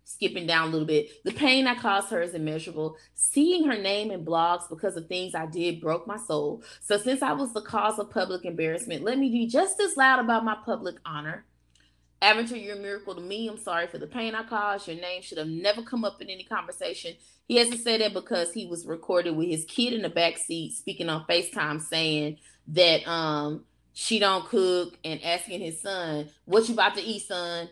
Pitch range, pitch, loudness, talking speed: 160-220 Hz, 180 Hz, -27 LUFS, 220 wpm